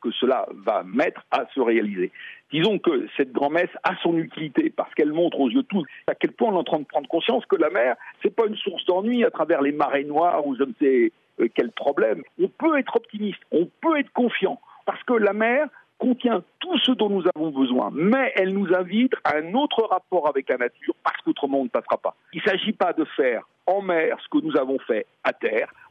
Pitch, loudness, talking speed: 225 Hz, -23 LUFS, 235 wpm